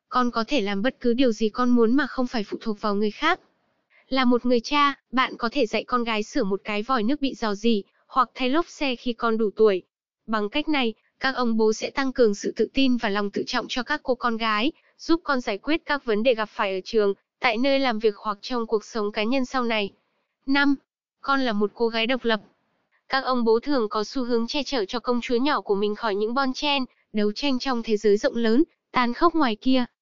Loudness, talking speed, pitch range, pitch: -24 LUFS, 250 wpm, 220-265 Hz, 240 Hz